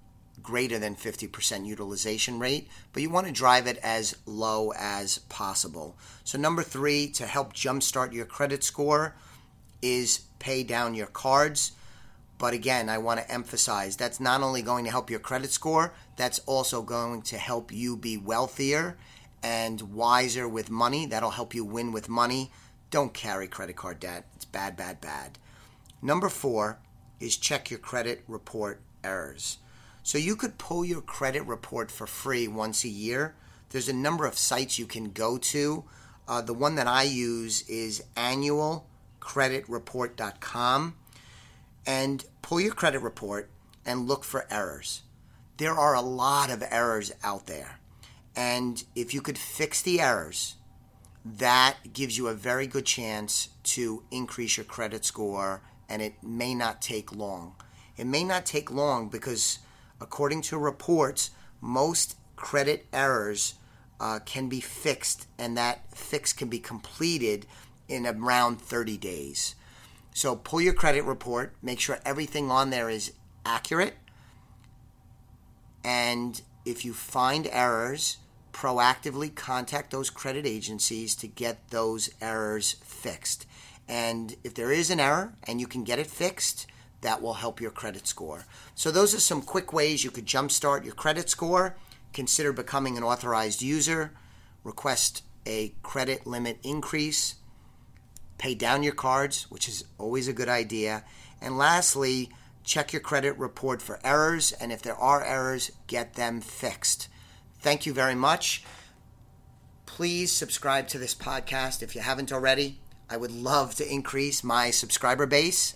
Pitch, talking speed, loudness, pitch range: 120 Hz, 150 wpm, -28 LUFS, 110-135 Hz